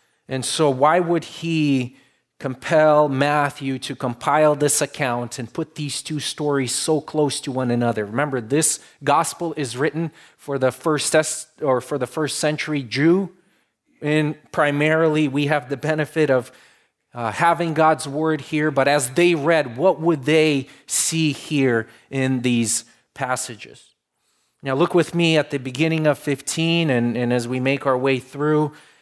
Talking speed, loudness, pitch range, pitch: 155 wpm, -20 LUFS, 130-155 Hz, 145 Hz